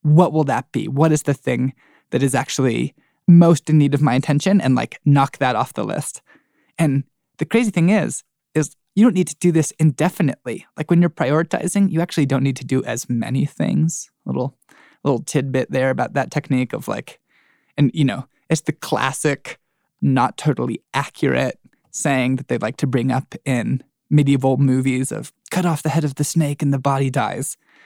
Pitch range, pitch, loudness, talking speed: 135-160 Hz, 145 Hz, -19 LUFS, 195 wpm